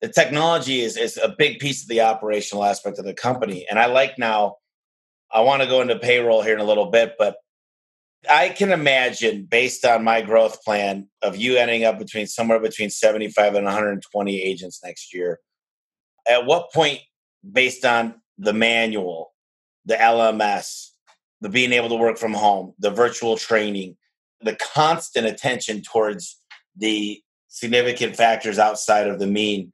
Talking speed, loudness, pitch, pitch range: 165 wpm, -20 LUFS, 115 Hz, 105-120 Hz